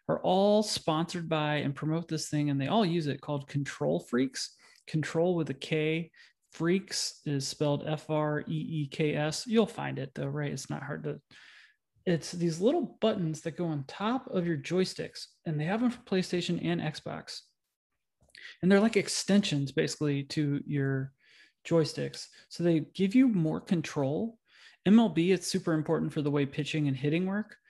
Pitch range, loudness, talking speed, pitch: 150-185 Hz, -30 LUFS, 180 wpm, 160 Hz